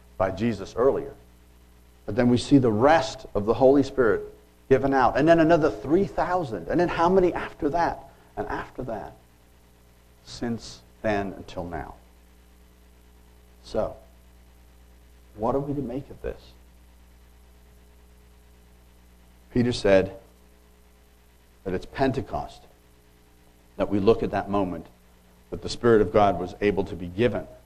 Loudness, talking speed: -24 LUFS, 130 wpm